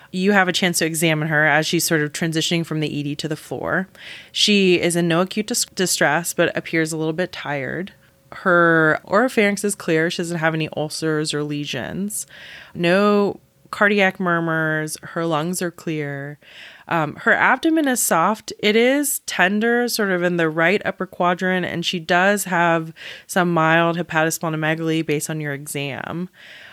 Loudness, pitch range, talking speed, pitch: -19 LUFS, 160-190 Hz, 170 wpm, 170 Hz